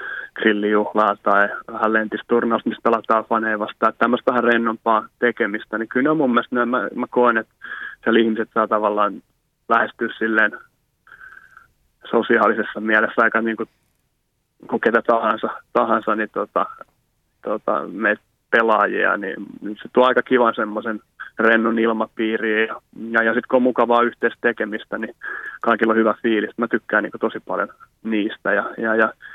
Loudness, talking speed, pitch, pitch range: -19 LUFS, 150 wpm, 115 Hz, 110-115 Hz